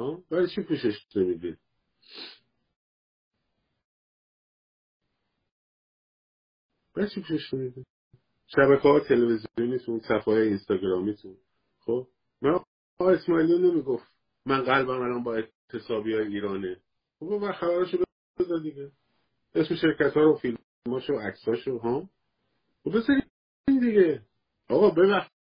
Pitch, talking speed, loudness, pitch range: 140 Hz, 100 wpm, -26 LUFS, 115-180 Hz